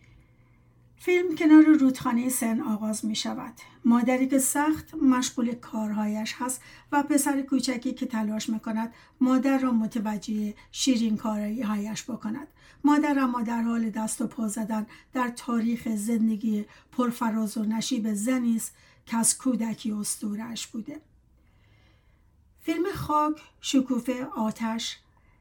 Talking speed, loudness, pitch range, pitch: 120 wpm, -26 LUFS, 220-260 Hz, 235 Hz